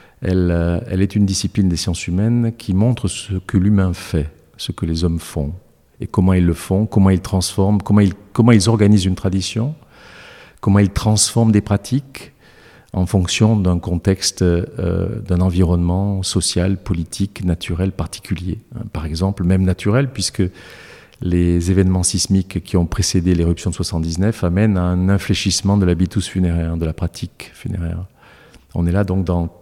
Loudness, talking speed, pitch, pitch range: -18 LUFS, 160 wpm, 95 Hz, 90-100 Hz